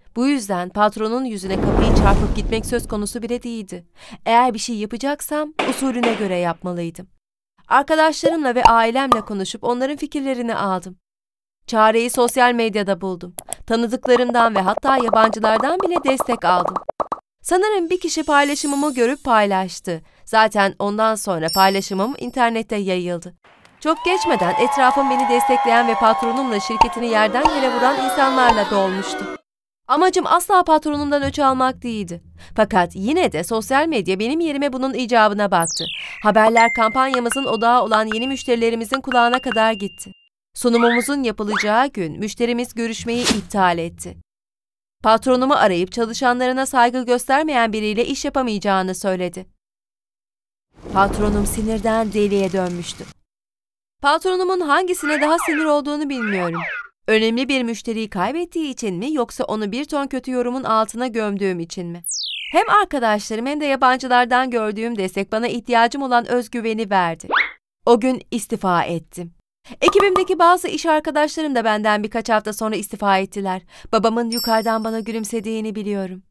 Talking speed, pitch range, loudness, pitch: 125 wpm, 205-265 Hz, -18 LUFS, 230 Hz